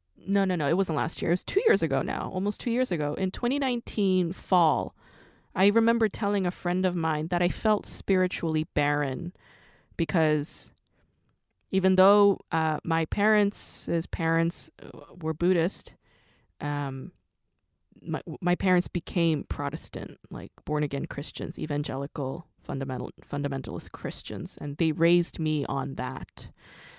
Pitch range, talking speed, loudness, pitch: 145-185 Hz, 140 wpm, -27 LUFS, 165 Hz